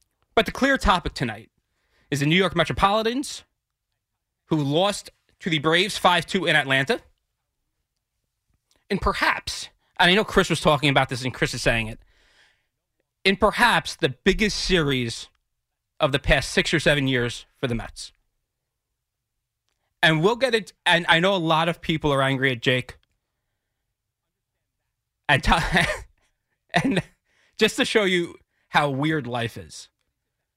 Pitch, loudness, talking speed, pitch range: 145 Hz, -22 LUFS, 145 wpm, 120-180 Hz